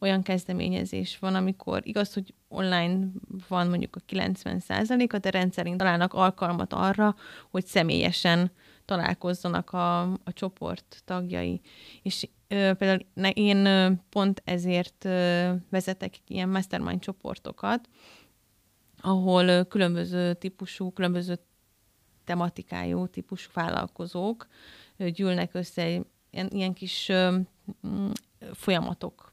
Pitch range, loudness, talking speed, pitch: 175-190 Hz, -28 LUFS, 100 wpm, 185 Hz